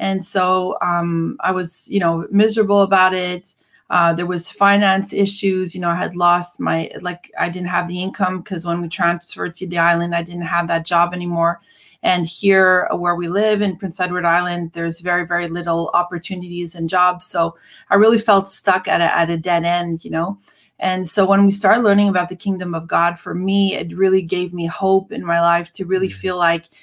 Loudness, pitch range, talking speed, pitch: -18 LUFS, 170-190 Hz, 210 wpm, 180 Hz